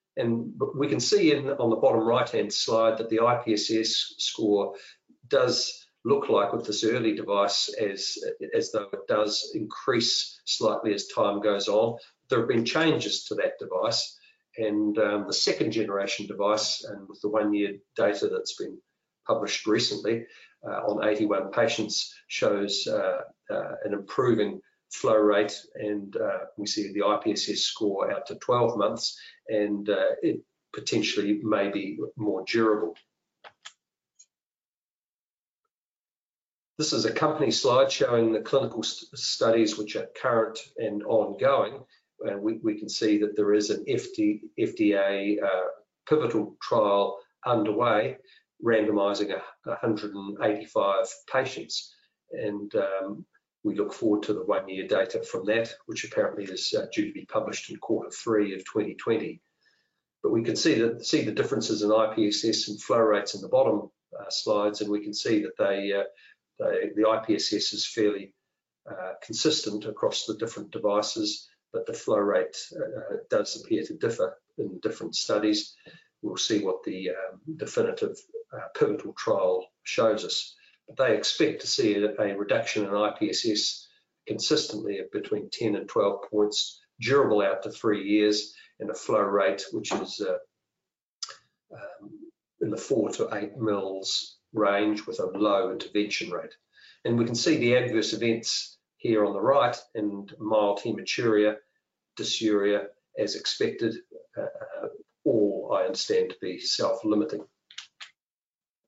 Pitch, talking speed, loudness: 120 Hz, 145 wpm, -27 LUFS